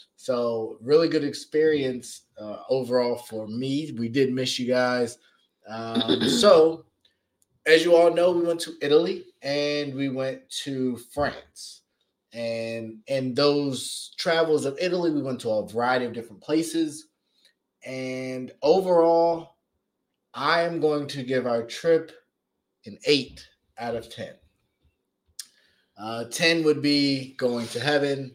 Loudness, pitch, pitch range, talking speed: -24 LUFS, 135 Hz, 120-155 Hz, 135 wpm